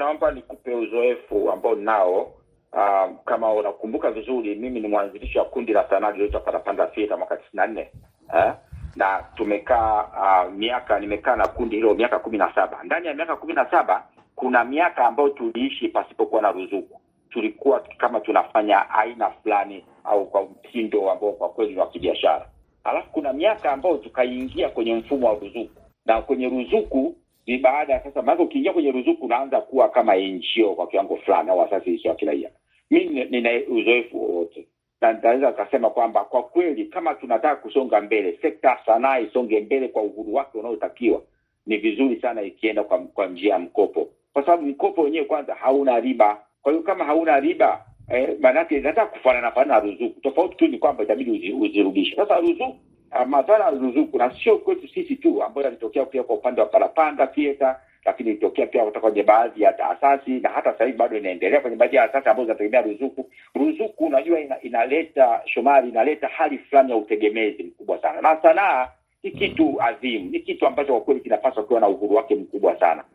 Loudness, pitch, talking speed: -21 LUFS, 320 Hz, 165 wpm